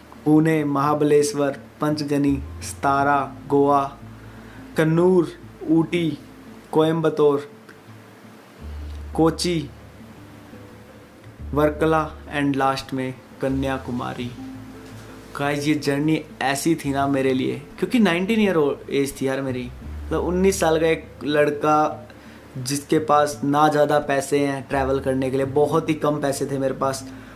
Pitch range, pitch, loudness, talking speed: 125-150 Hz, 140 Hz, -21 LUFS, 115 wpm